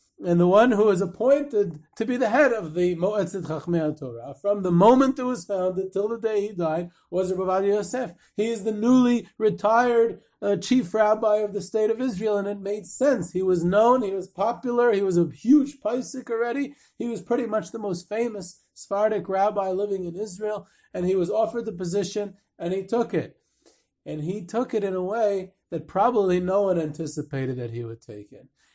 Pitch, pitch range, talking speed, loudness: 205 Hz, 180-230 Hz, 200 wpm, -24 LUFS